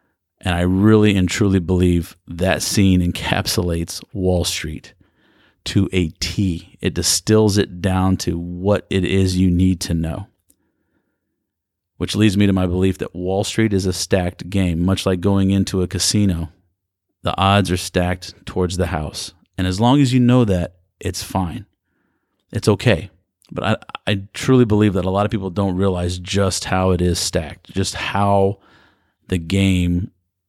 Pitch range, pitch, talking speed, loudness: 90-100 Hz, 95 Hz, 165 wpm, -18 LUFS